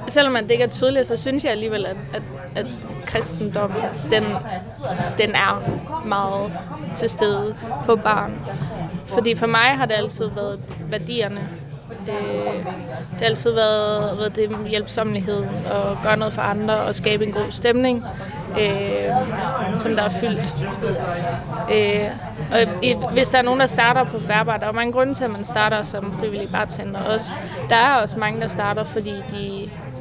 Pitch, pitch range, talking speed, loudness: 210 Hz, 190-230 Hz, 160 wpm, -21 LUFS